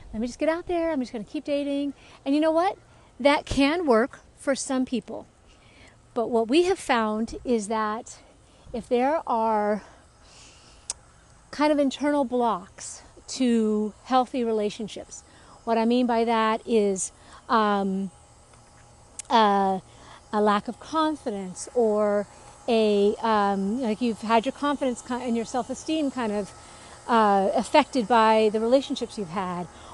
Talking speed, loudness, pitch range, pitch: 140 wpm, -25 LUFS, 210-265 Hz, 230 Hz